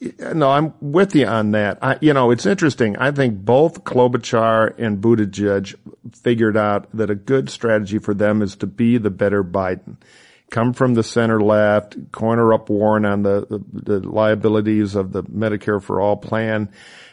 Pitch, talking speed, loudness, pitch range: 110 Hz, 175 wpm, -18 LUFS, 105-120 Hz